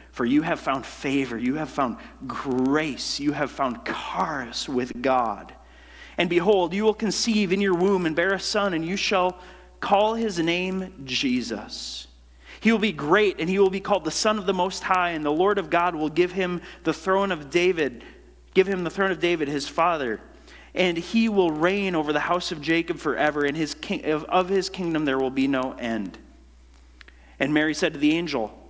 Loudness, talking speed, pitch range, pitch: -24 LUFS, 205 wpm, 145-190 Hz, 175 Hz